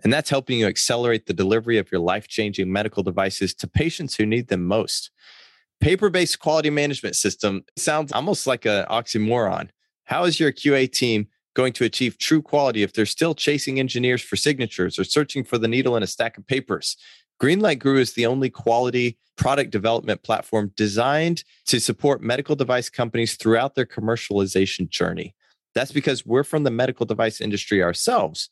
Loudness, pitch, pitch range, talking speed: -22 LUFS, 120 Hz, 110-145 Hz, 175 wpm